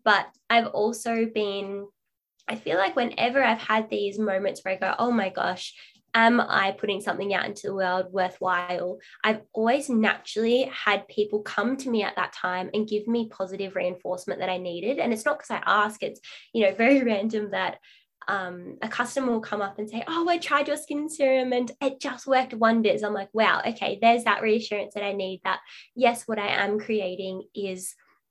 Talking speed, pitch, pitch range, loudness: 200 wpm, 210 Hz, 195-235 Hz, -26 LUFS